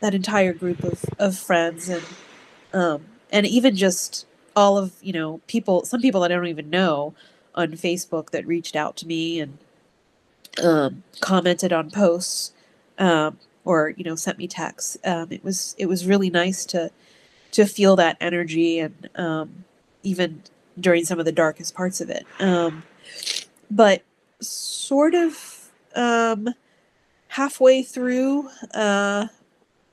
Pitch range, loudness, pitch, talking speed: 170-205 Hz, -22 LUFS, 180 Hz, 145 wpm